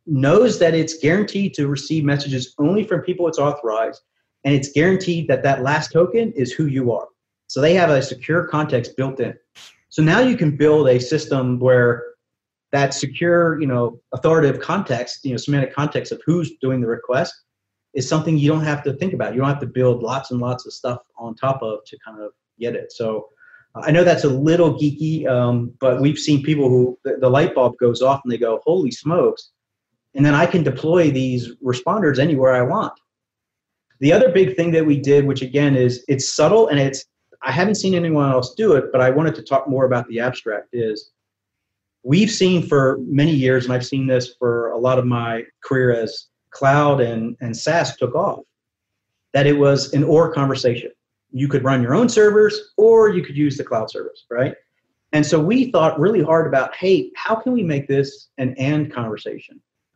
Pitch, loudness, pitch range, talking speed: 140 Hz, -18 LUFS, 125-160 Hz, 205 wpm